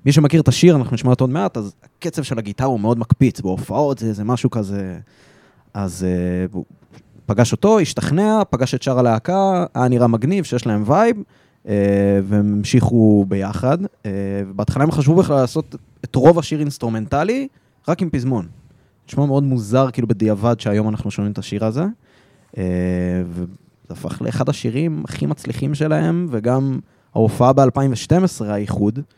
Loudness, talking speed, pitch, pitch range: -18 LUFS, 160 wpm, 125 Hz, 105-145 Hz